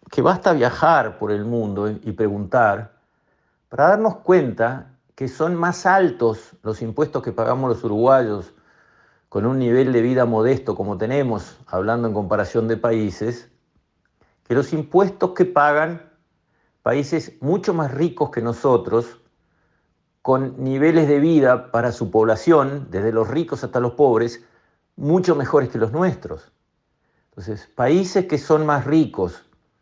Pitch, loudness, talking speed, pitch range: 125 Hz, -19 LUFS, 140 wpm, 115-155 Hz